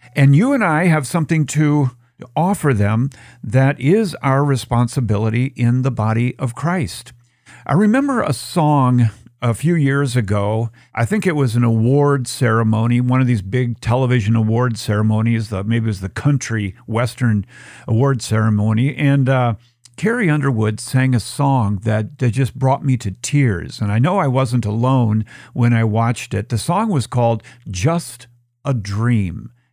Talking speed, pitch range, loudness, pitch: 155 wpm, 115-140 Hz, -17 LUFS, 125 Hz